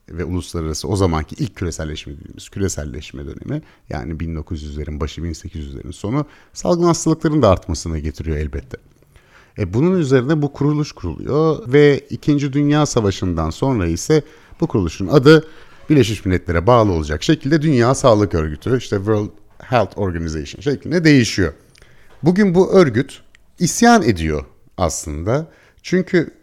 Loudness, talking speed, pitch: -17 LUFS, 125 wpm, 105 Hz